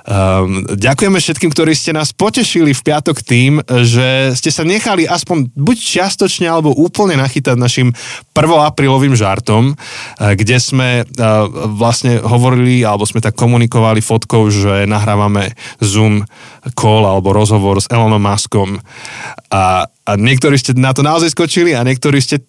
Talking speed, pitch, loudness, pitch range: 140 wpm, 125 Hz, -11 LUFS, 110-150 Hz